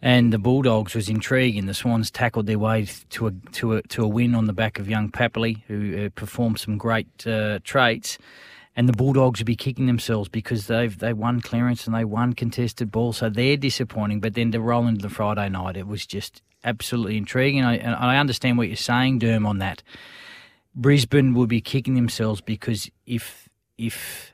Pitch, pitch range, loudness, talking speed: 115 Hz, 110-120 Hz, -23 LUFS, 200 wpm